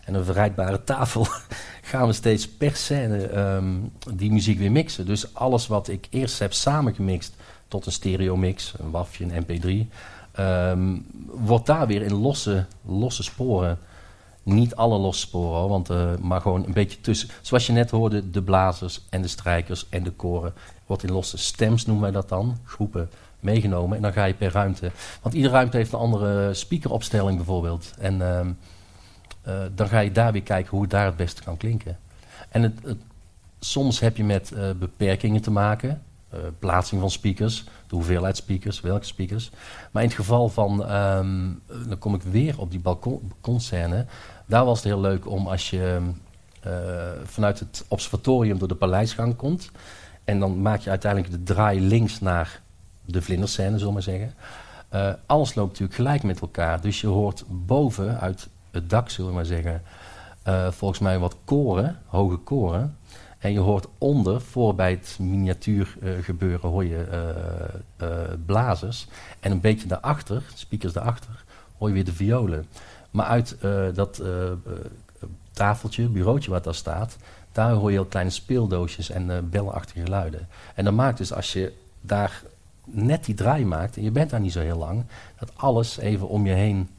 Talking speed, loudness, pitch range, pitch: 180 wpm, -24 LUFS, 90-110 Hz, 100 Hz